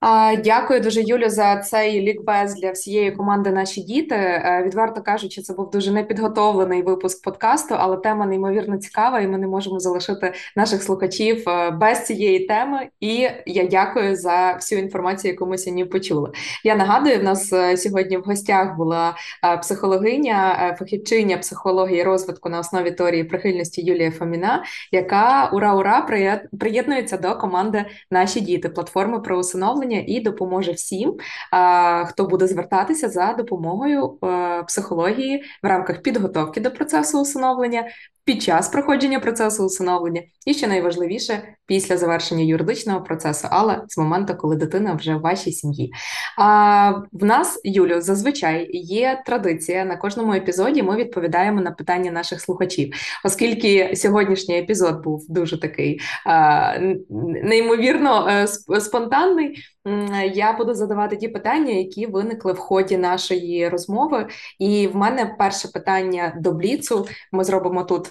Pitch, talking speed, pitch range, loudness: 195 Hz, 135 wpm, 180-215 Hz, -20 LUFS